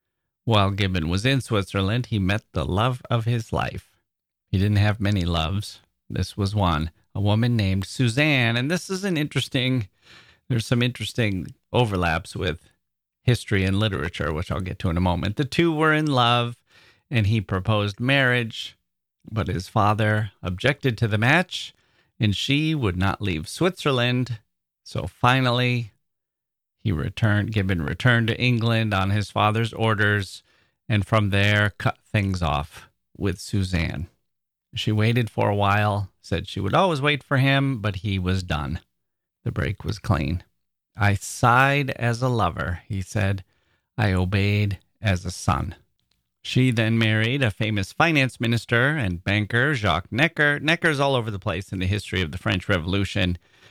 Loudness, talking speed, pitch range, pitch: -23 LUFS, 160 wpm, 95-120 Hz, 105 Hz